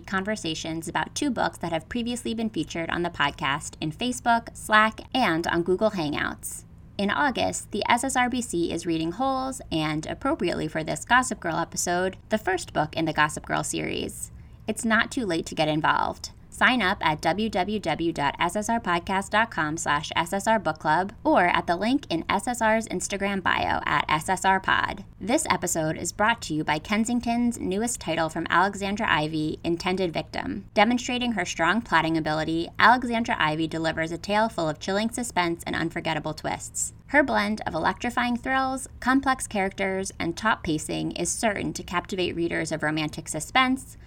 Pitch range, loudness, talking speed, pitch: 160-230 Hz, -25 LUFS, 155 wpm, 185 Hz